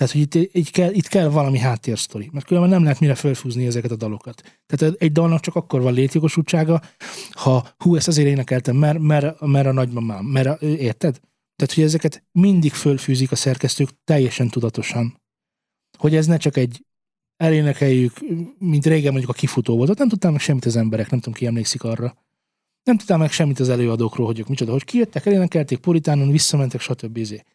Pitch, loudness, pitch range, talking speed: 140 Hz, -19 LUFS, 125-160 Hz, 185 wpm